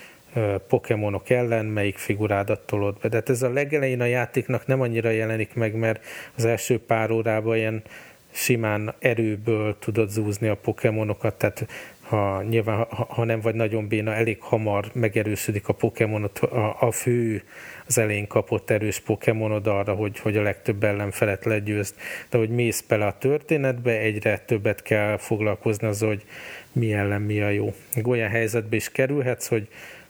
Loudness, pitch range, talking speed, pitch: -24 LUFS, 105-115 Hz, 160 wpm, 110 Hz